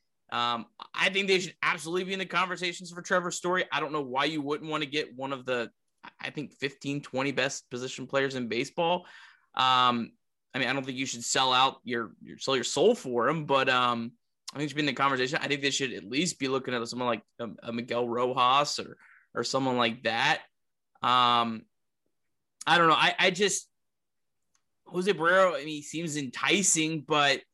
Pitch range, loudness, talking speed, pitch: 125-160 Hz, -28 LUFS, 205 wpm, 140 Hz